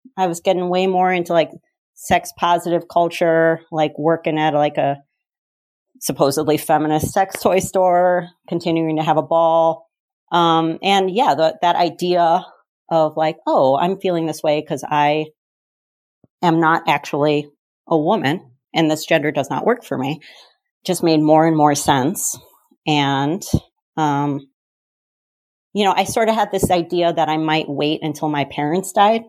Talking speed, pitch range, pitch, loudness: 160 wpm, 150-180 Hz, 165 Hz, -18 LUFS